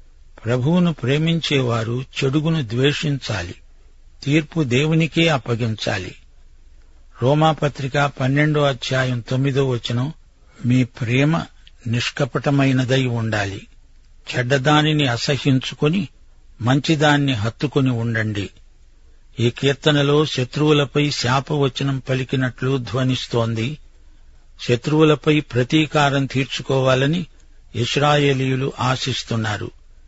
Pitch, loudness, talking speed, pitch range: 130 Hz, -19 LUFS, 65 wpm, 115-145 Hz